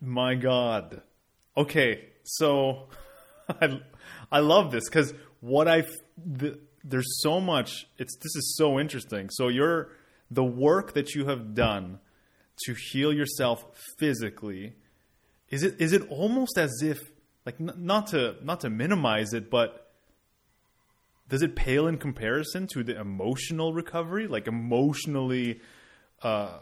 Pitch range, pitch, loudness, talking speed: 120-155 Hz, 140 Hz, -27 LUFS, 135 wpm